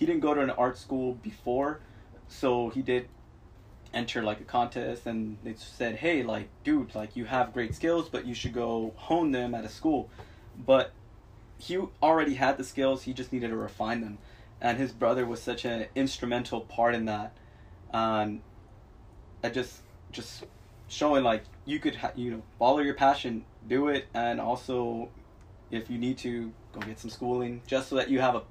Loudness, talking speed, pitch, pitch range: -30 LUFS, 185 wpm, 120 Hz, 110-130 Hz